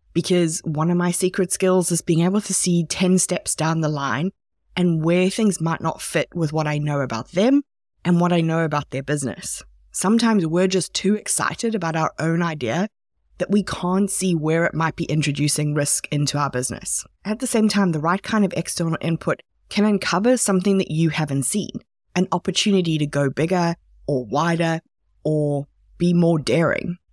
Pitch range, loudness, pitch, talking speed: 155-190 Hz, -21 LUFS, 170 Hz, 190 wpm